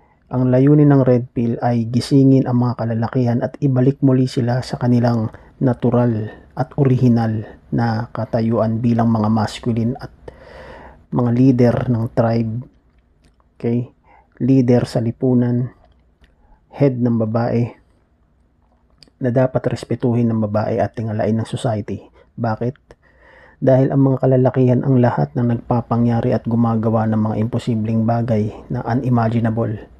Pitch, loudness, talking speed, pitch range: 120 Hz, -17 LUFS, 125 wpm, 110-125 Hz